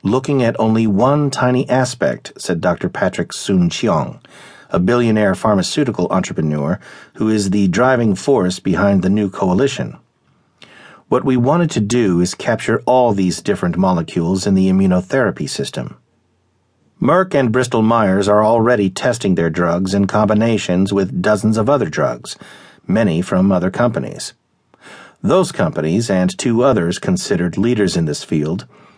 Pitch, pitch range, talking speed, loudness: 110 Hz, 95-125 Hz, 145 wpm, -16 LUFS